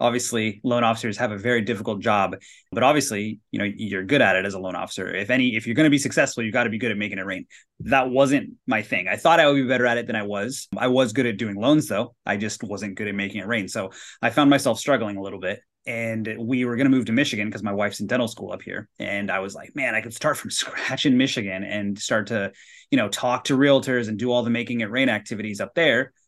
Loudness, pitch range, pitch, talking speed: -23 LUFS, 105-125 Hz, 115 Hz, 275 wpm